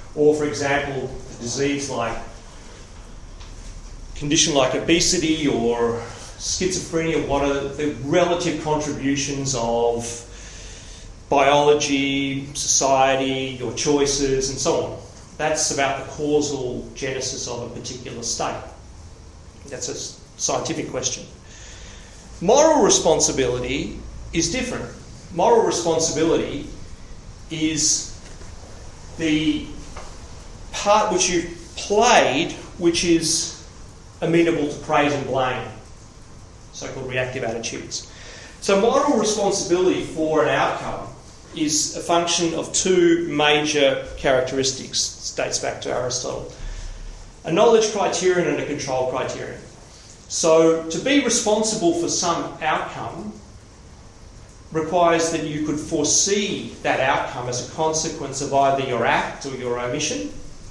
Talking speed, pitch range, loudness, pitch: 110 wpm, 115-160 Hz, -21 LUFS, 140 Hz